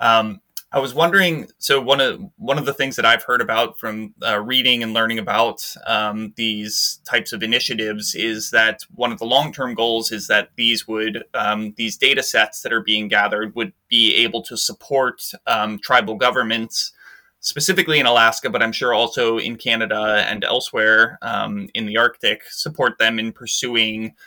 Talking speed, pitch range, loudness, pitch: 180 wpm, 110-130 Hz, -18 LUFS, 115 Hz